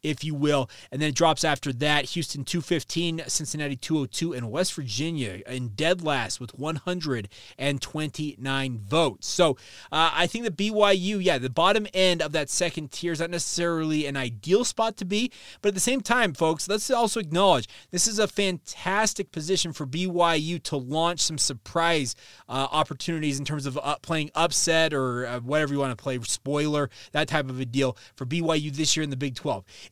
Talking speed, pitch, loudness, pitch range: 195 wpm, 155 Hz, -26 LUFS, 140-175 Hz